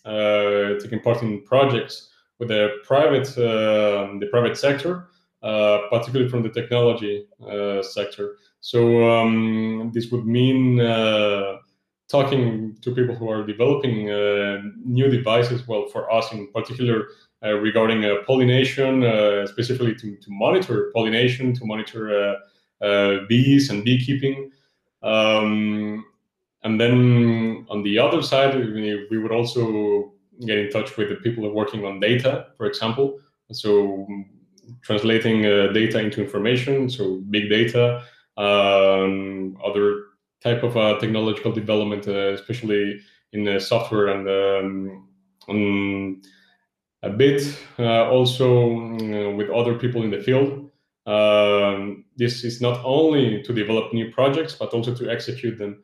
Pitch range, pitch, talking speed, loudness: 105-120 Hz, 110 Hz, 140 wpm, -21 LUFS